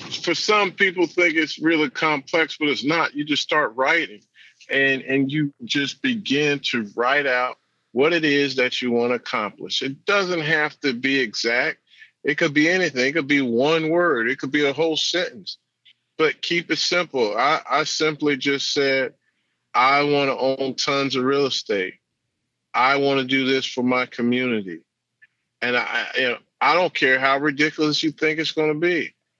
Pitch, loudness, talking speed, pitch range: 145 Hz, -21 LUFS, 185 wpm, 135-160 Hz